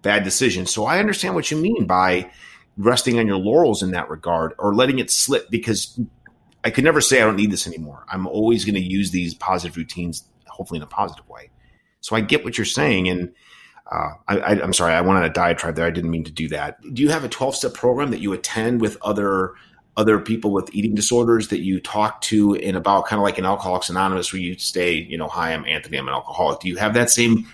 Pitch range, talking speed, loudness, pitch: 90-115 Hz, 245 wpm, -20 LUFS, 100 Hz